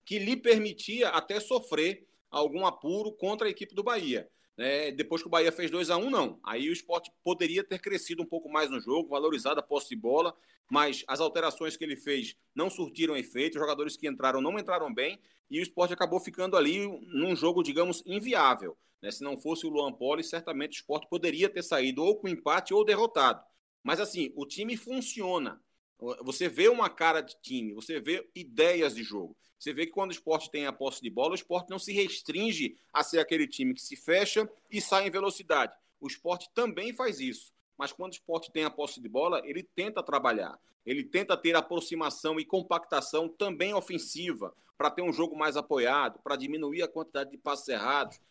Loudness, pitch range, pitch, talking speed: -31 LUFS, 150-205 Hz, 170 Hz, 205 wpm